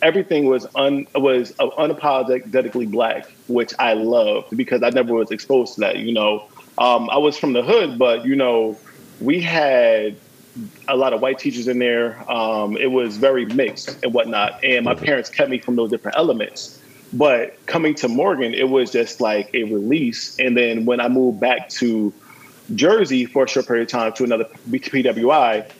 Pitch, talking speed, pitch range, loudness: 130 Hz, 185 wpm, 120-140 Hz, -18 LUFS